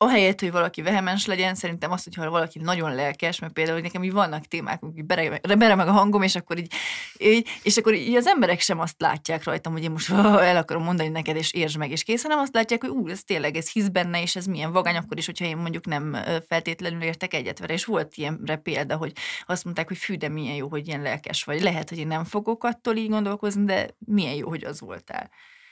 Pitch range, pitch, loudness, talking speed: 160-205 Hz, 175 Hz, -24 LUFS, 235 wpm